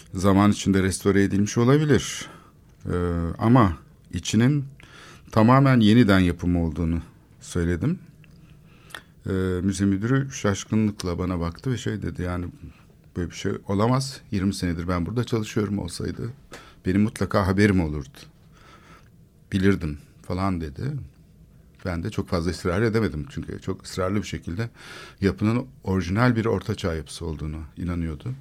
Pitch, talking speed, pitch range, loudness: 100 Hz, 125 wpm, 90-115 Hz, -24 LUFS